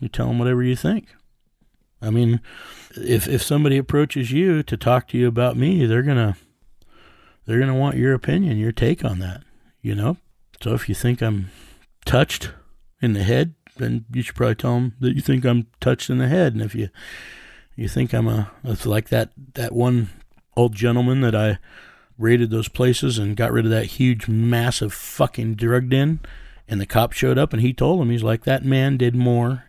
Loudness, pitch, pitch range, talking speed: -20 LUFS, 120 Hz, 110-130 Hz, 205 wpm